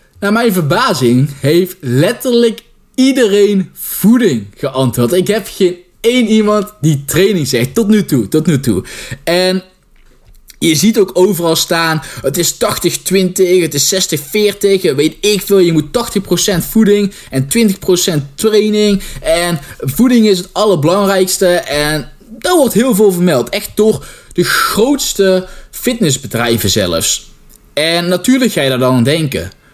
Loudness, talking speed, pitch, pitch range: -12 LUFS, 140 wpm, 185 Hz, 155-210 Hz